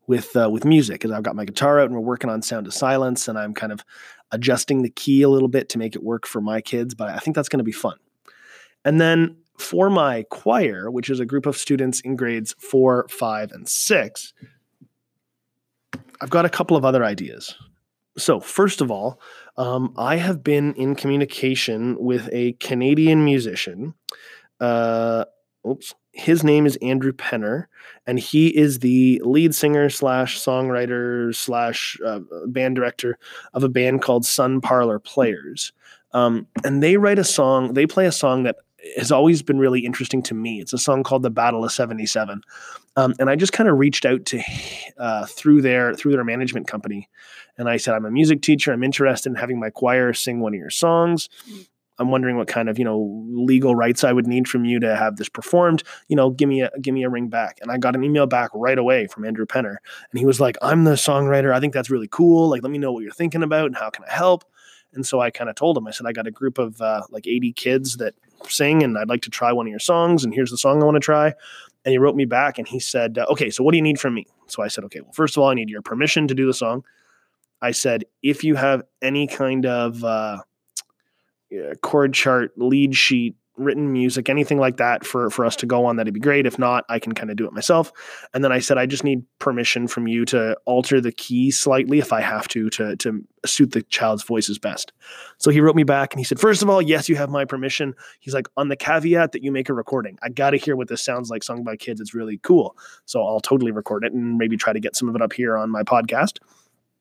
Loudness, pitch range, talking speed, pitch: -20 LUFS, 120-145 Hz, 235 wpm, 130 Hz